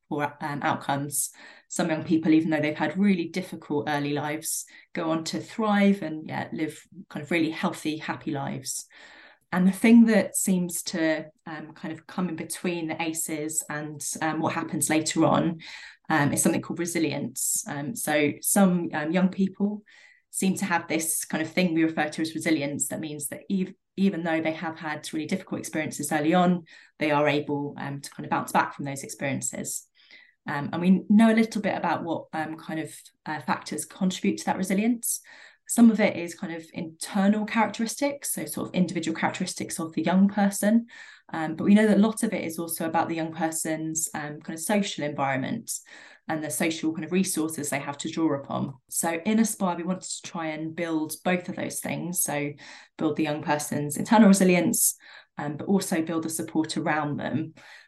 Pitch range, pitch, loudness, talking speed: 155-190 Hz, 165 Hz, -26 LUFS, 195 wpm